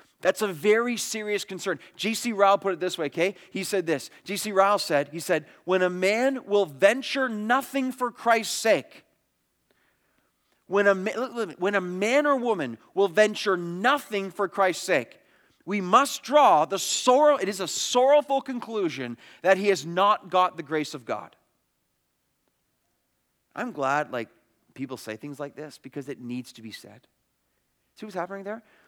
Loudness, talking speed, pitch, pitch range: -25 LUFS, 160 wpm, 195 Hz, 165-220 Hz